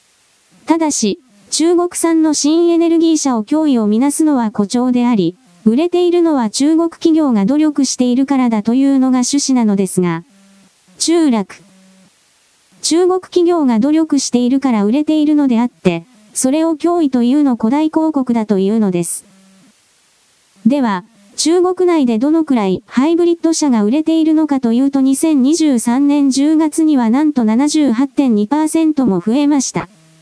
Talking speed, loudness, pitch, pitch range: 295 characters per minute, -13 LUFS, 270 Hz, 225-310 Hz